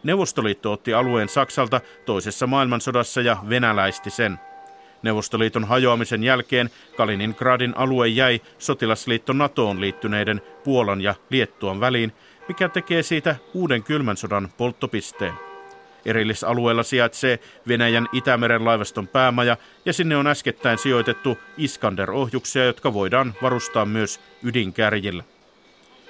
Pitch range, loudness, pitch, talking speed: 110-130 Hz, -21 LUFS, 120 Hz, 105 wpm